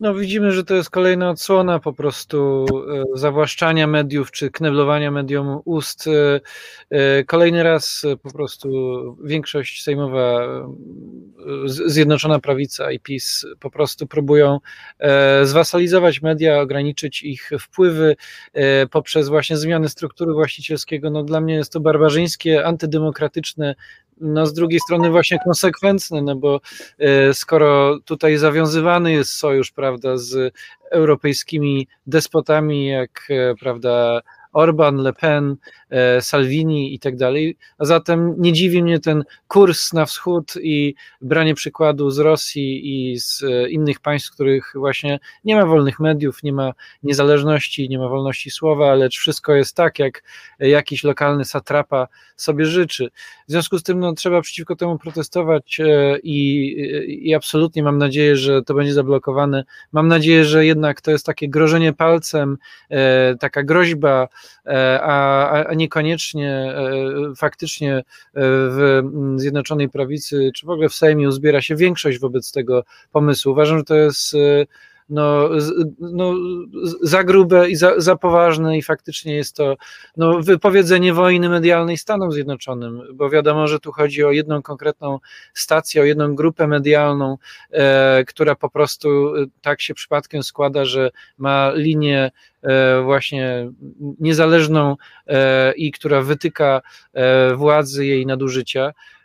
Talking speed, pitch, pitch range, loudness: 135 wpm, 150 Hz, 140-160 Hz, -17 LUFS